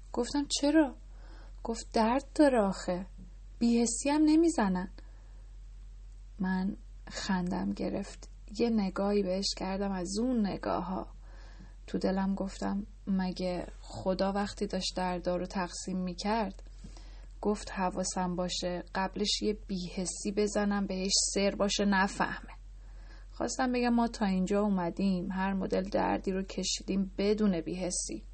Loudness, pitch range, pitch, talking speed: -31 LUFS, 180-210 Hz, 195 Hz, 115 wpm